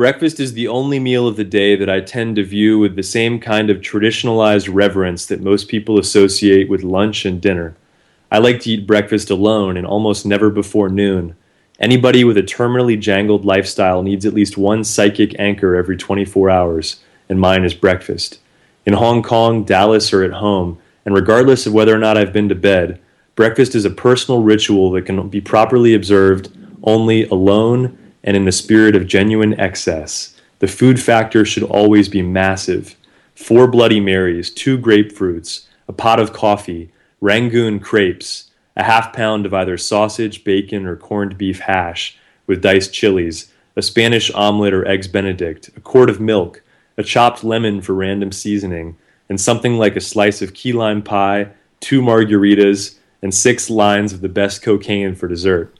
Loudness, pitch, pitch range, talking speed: -14 LUFS, 105 Hz, 95-110 Hz, 175 wpm